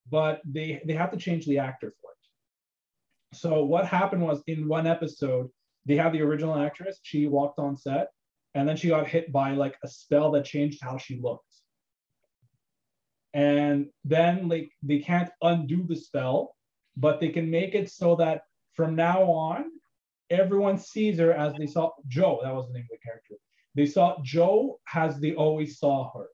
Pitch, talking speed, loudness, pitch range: 155 Hz, 180 wpm, -27 LUFS, 140-170 Hz